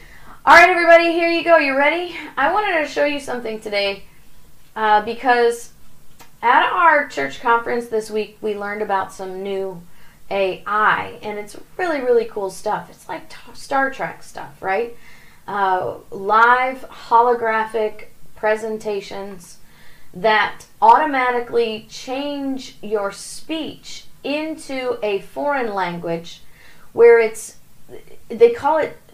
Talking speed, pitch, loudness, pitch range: 120 wpm, 230 Hz, -18 LUFS, 205-290 Hz